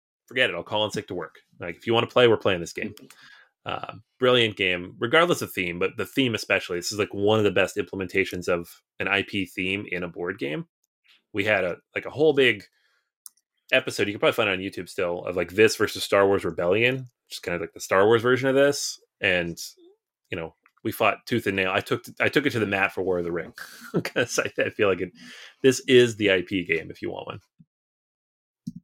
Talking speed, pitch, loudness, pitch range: 240 wpm, 105 Hz, -24 LUFS, 95-125 Hz